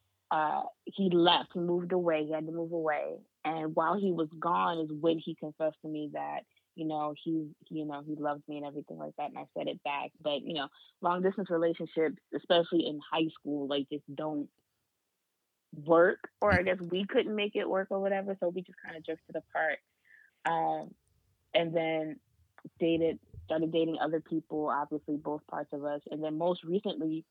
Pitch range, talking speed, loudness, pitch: 150-175 Hz, 190 wpm, -33 LUFS, 160 Hz